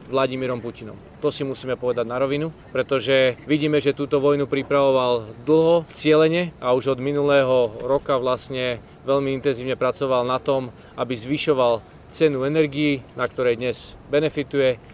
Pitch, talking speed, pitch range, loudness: 135 Hz, 140 wpm, 125-145 Hz, -22 LUFS